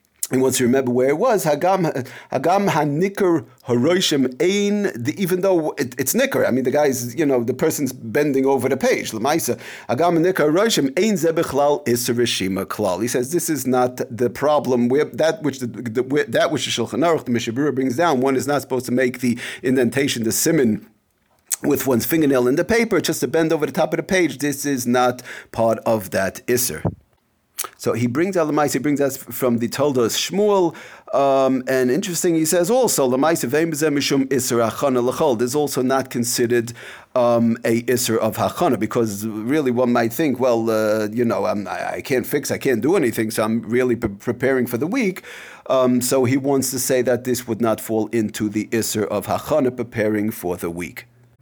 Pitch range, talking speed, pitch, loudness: 120-150 Hz, 185 wpm, 130 Hz, -19 LUFS